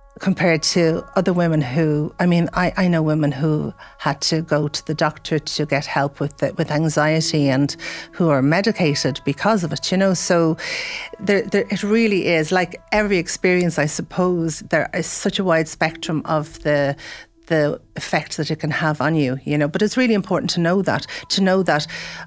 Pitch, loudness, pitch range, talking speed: 165 Hz, -19 LUFS, 150-185 Hz, 195 wpm